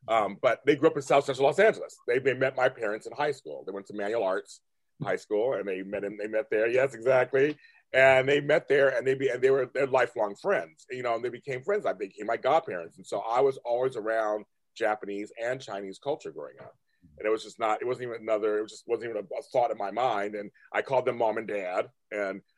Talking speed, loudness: 260 wpm, -28 LUFS